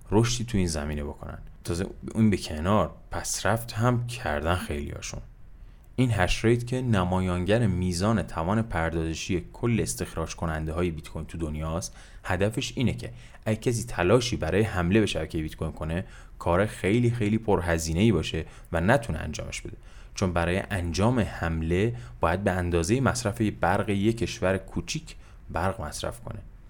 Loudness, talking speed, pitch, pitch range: -27 LUFS, 150 wpm, 95 Hz, 85-115 Hz